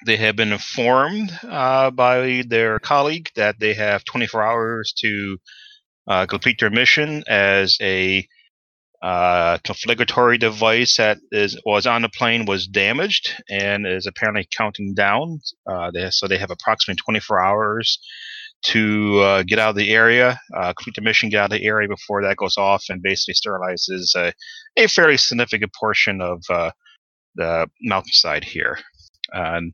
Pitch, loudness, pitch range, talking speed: 110 Hz, -18 LUFS, 100-125 Hz, 155 wpm